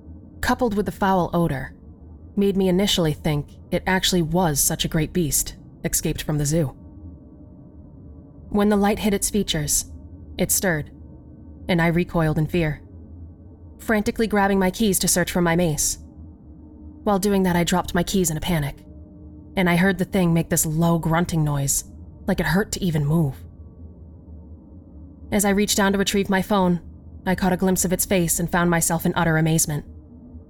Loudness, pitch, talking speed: -21 LUFS, 165 Hz, 175 wpm